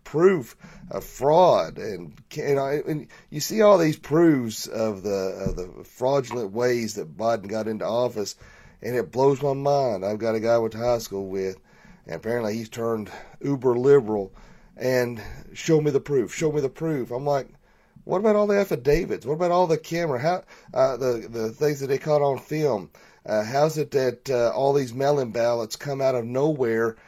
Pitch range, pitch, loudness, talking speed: 115-150 Hz, 130 Hz, -24 LUFS, 195 wpm